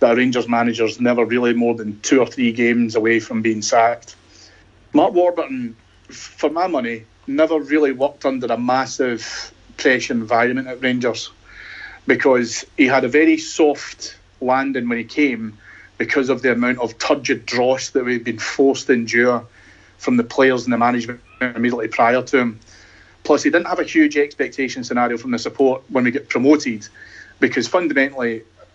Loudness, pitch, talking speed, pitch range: -18 LUFS, 120 Hz, 165 wpm, 115-135 Hz